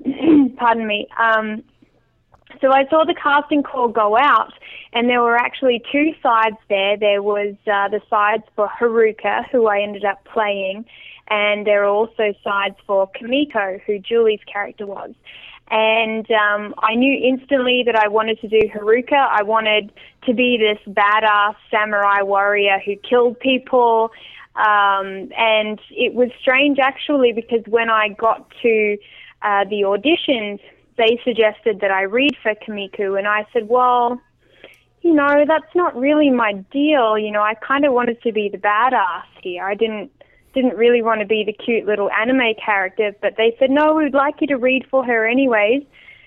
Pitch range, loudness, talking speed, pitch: 210-255 Hz, -17 LUFS, 170 wpm, 225 Hz